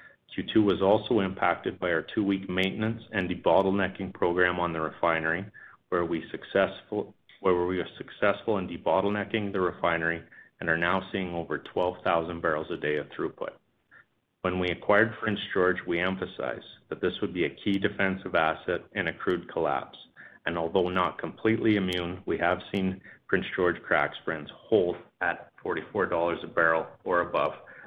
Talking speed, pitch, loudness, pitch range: 160 wpm, 95 Hz, -28 LUFS, 85-100 Hz